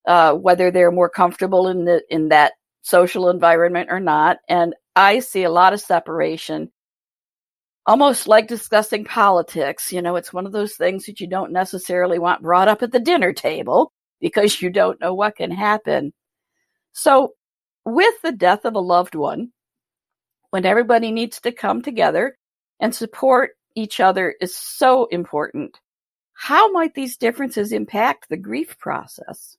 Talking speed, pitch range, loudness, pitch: 160 wpm, 175-235 Hz, -18 LUFS, 190 Hz